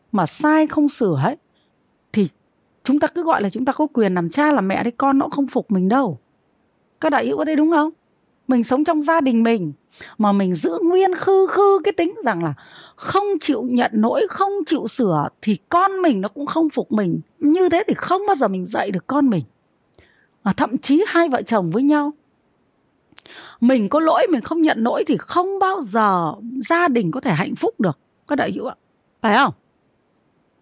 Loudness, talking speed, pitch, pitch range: -19 LUFS, 210 wpm, 275 Hz, 225-330 Hz